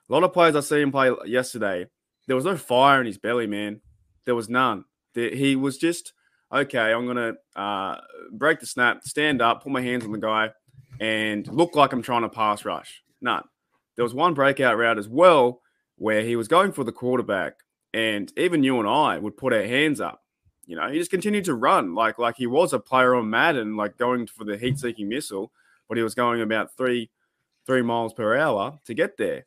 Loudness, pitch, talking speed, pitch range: -23 LUFS, 125 Hz, 215 wpm, 110-140 Hz